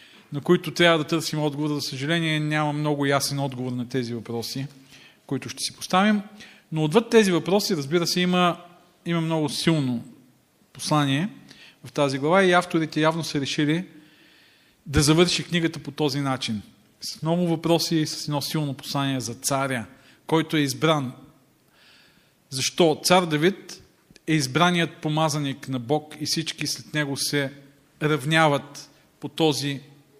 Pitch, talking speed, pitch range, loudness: 150 Hz, 145 wpm, 140-165 Hz, -23 LUFS